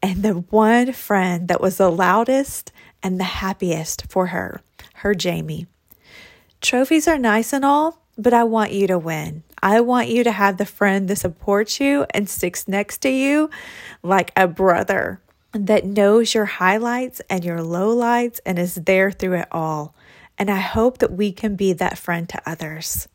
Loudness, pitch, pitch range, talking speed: -19 LUFS, 200 Hz, 180-230 Hz, 175 wpm